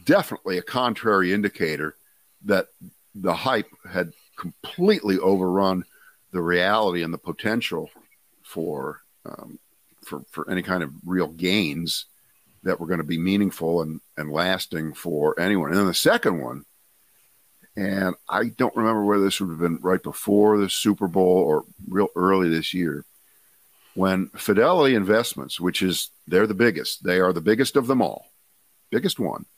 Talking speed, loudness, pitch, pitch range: 155 wpm, -23 LUFS, 95 Hz, 85-100 Hz